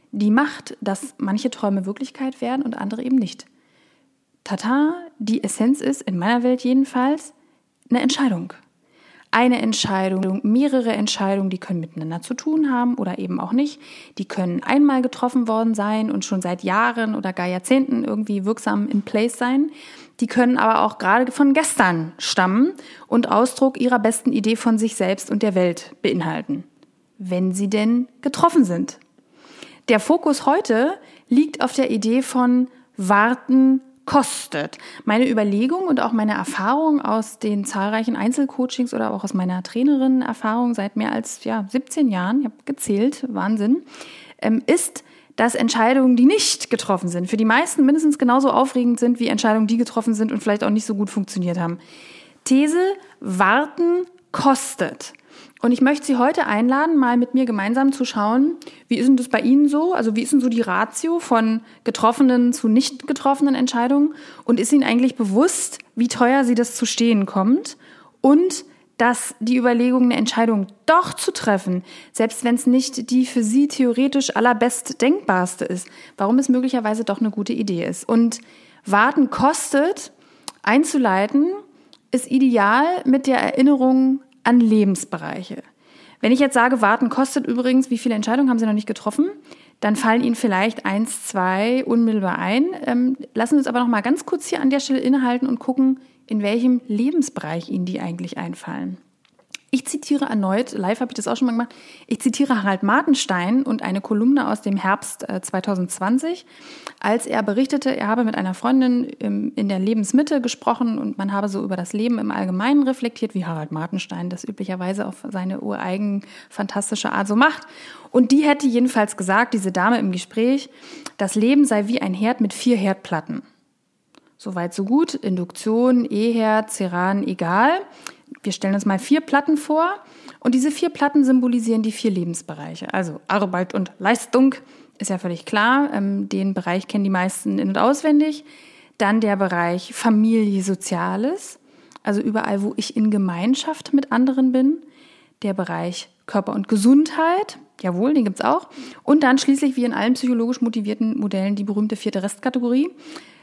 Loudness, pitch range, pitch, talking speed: -20 LUFS, 210-275 Hz, 245 Hz, 165 wpm